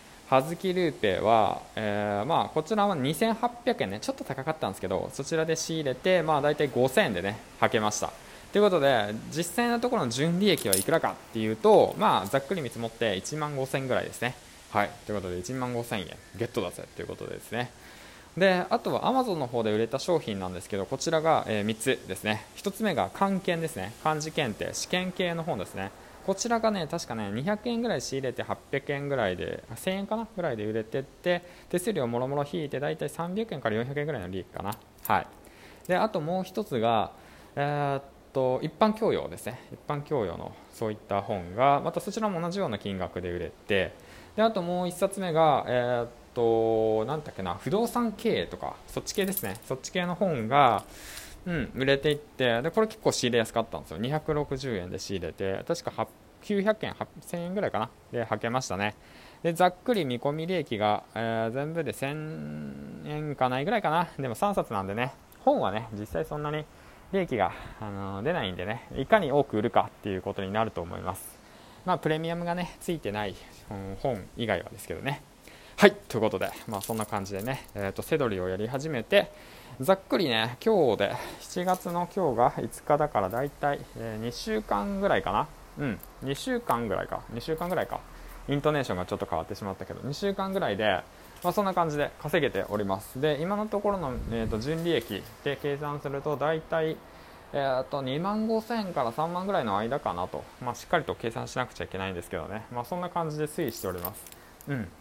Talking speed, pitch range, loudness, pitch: 375 characters per minute, 110-175 Hz, -29 LUFS, 140 Hz